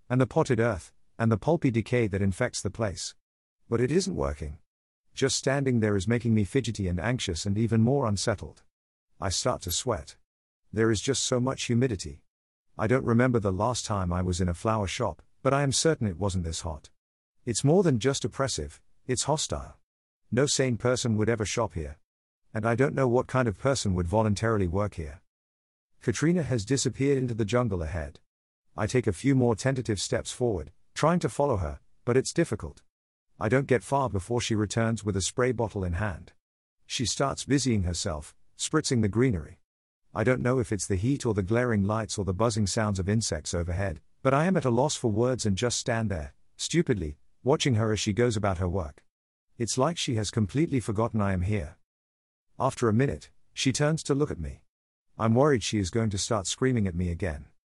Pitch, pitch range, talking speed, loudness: 115 Hz, 95-130 Hz, 205 wpm, -27 LUFS